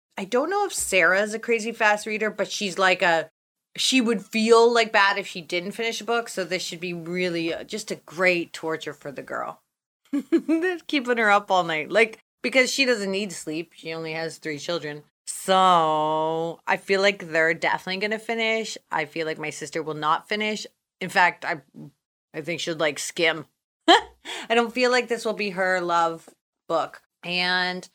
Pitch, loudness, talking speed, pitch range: 185 Hz, -23 LUFS, 190 wpm, 165-225 Hz